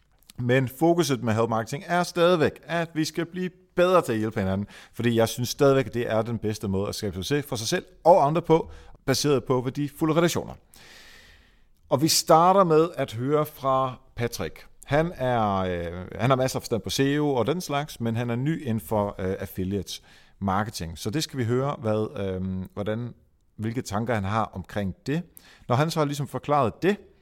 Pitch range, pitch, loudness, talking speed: 105-150 Hz, 125 Hz, -25 LUFS, 200 wpm